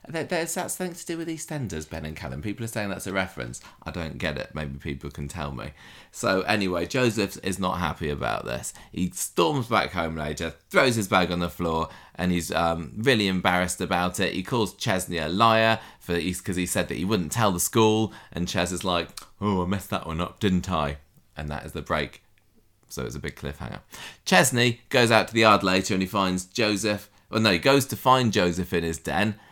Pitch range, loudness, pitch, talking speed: 85-110 Hz, -25 LUFS, 95 Hz, 220 wpm